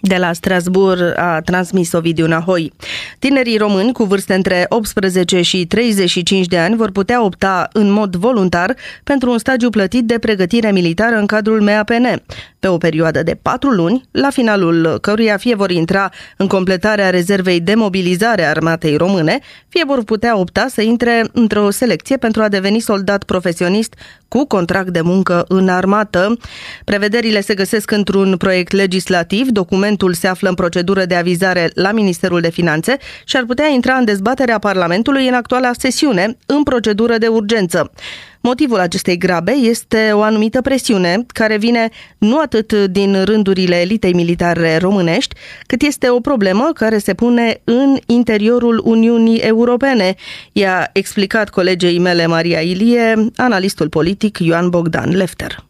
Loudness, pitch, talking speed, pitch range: -14 LUFS, 200 Hz, 150 wpm, 180-230 Hz